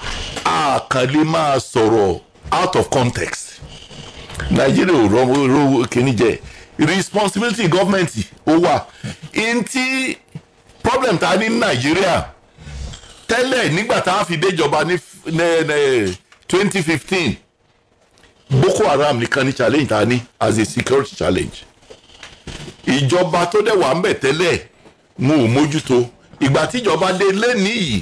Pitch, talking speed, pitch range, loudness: 165 Hz, 105 wpm, 130-195 Hz, -16 LUFS